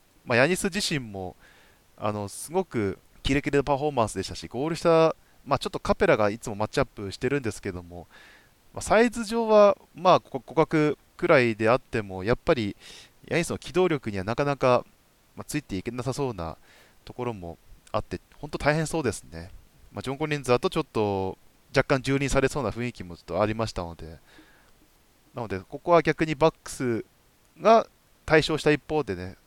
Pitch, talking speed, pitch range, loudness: 125 Hz, 365 characters per minute, 100-155 Hz, -26 LUFS